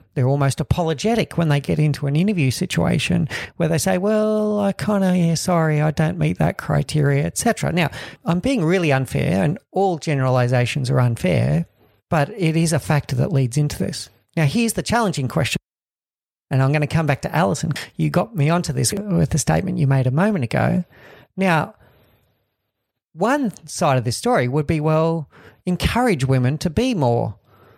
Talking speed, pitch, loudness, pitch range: 180 wpm, 155 Hz, -20 LUFS, 135-180 Hz